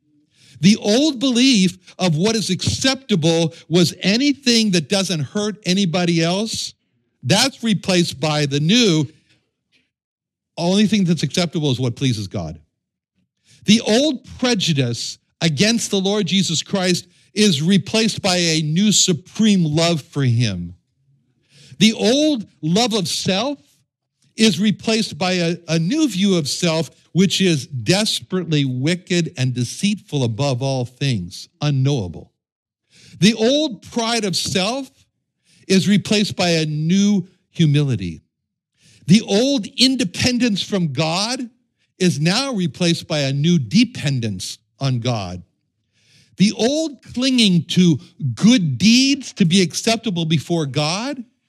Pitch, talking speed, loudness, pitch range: 175 Hz, 120 wpm, -18 LUFS, 145-210 Hz